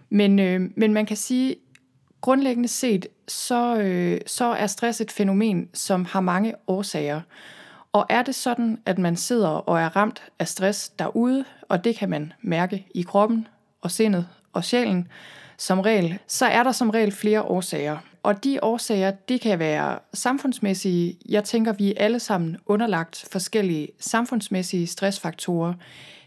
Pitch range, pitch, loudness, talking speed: 180-225 Hz, 205 Hz, -23 LUFS, 155 wpm